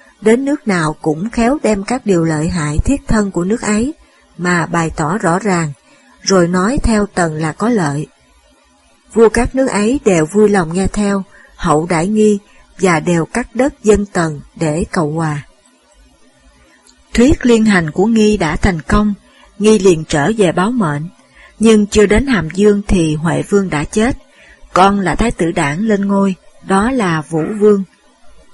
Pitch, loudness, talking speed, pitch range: 195 Hz, -14 LUFS, 175 wpm, 170-215 Hz